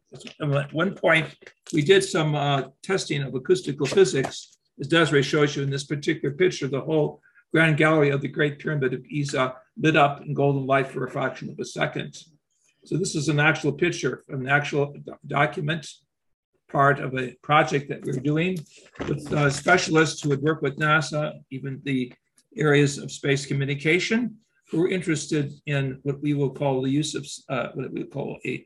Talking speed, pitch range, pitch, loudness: 180 wpm, 140-160 Hz, 145 Hz, -24 LUFS